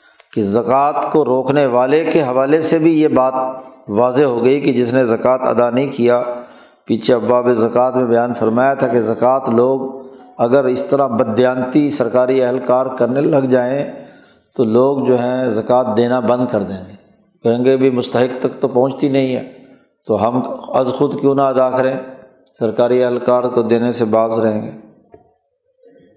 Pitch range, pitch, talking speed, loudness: 120-135 Hz, 125 Hz, 170 wpm, -15 LUFS